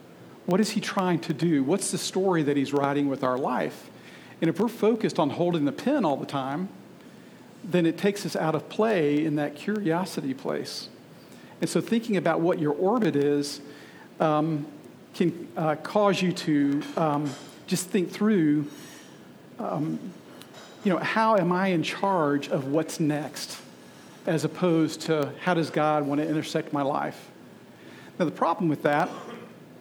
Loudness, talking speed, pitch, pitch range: -26 LUFS, 165 wpm, 160 Hz, 145-185 Hz